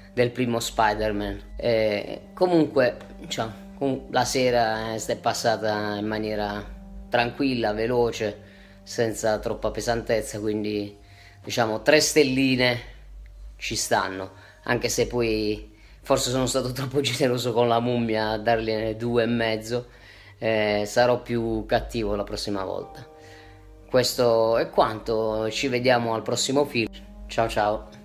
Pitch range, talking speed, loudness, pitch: 105-125 Hz, 120 wpm, -24 LUFS, 115 Hz